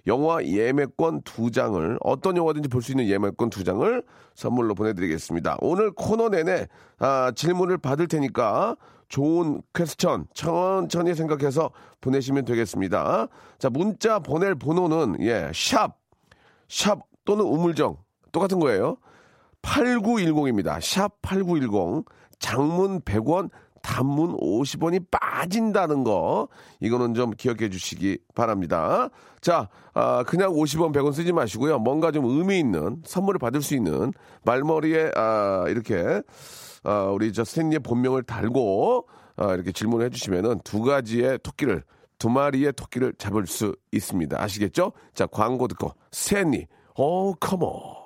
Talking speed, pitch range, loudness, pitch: 270 characters per minute, 115-170 Hz, -24 LUFS, 140 Hz